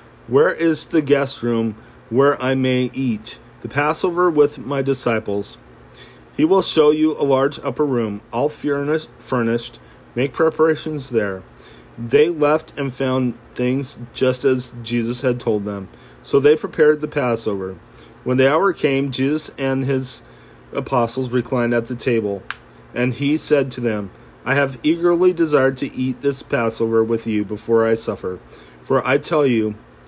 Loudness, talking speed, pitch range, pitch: -19 LUFS, 155 wpm, 115-145 Hz, 130 Hz